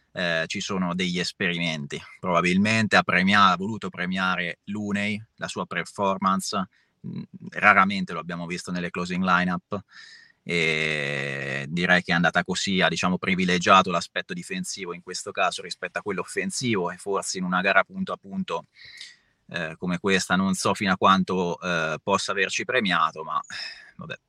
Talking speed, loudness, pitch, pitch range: 155 wpm, -24 LUFS, 90 Hz, 85-100 Hz